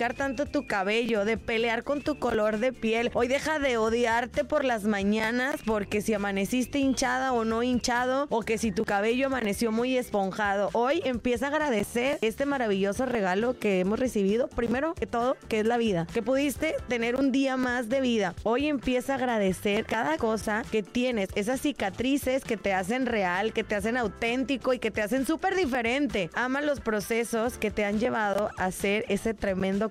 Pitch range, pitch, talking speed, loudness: 215-260 Hz, 235 Hz, 185 wpm, -27 LUFS